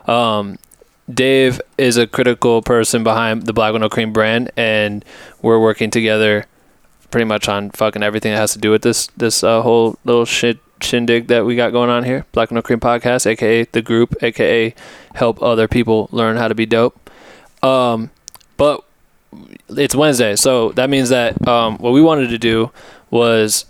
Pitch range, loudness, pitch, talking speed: 110-120 Hz, -15 LUFS, 115 Hz, 175 wpm